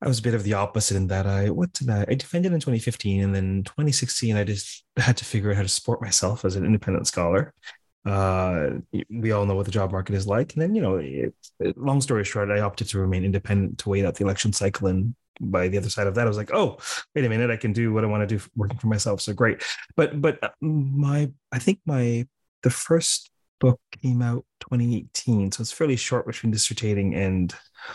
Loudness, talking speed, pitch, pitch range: -24 LUFS, 235 wpm, 110 Hz, 100-125 Hz